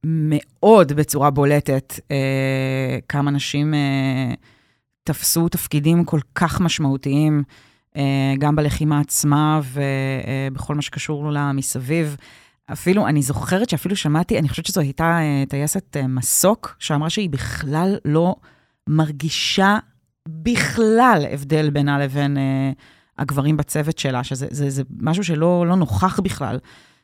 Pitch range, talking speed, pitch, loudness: 135-160 Hz, 125 wpm, 145 Hz, -19 LUFS